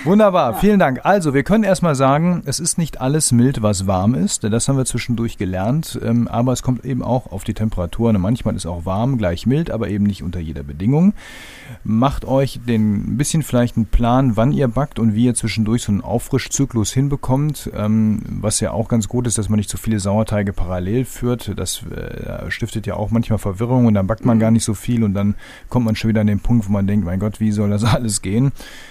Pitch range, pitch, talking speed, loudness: 105-130 Hz, 115 Hz, 220 wpm, -18 LUFS